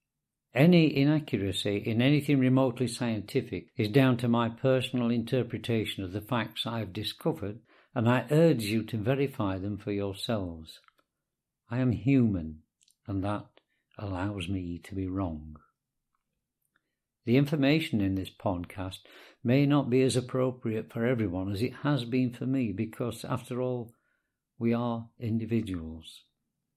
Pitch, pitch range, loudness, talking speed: 115 Hz, 100-130 Hz, -29 LUFS, 135 wpm